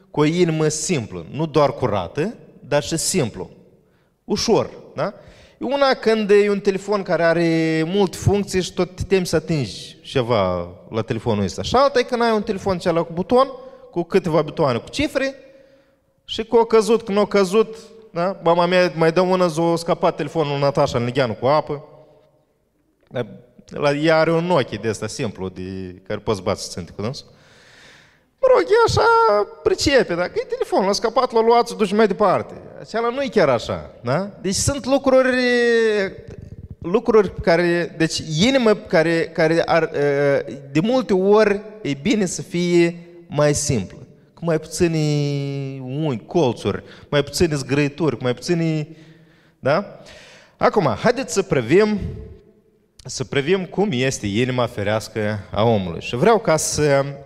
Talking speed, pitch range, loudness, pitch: 155 wpm, 145-210 Hz, -19 LUFS, 170 Hz